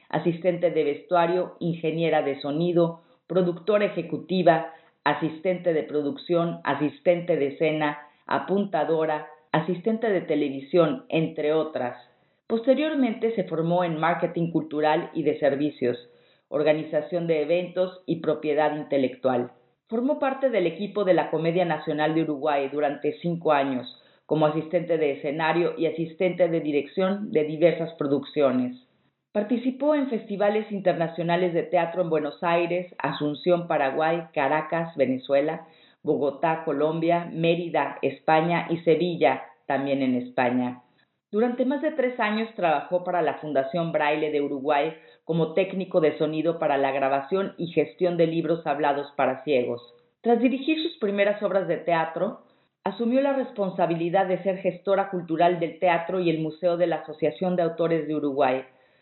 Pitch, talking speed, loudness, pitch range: 165 Hz, 135 wpm, -25 LUFS, 150-180 Hz